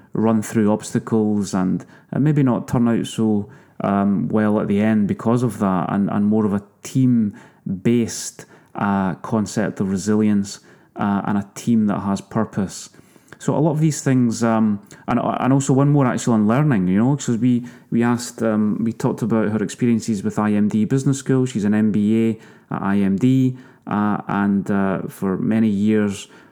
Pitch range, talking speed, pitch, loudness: 105-125 Hz, 175 wpm, 110 Hz, -19 LUFS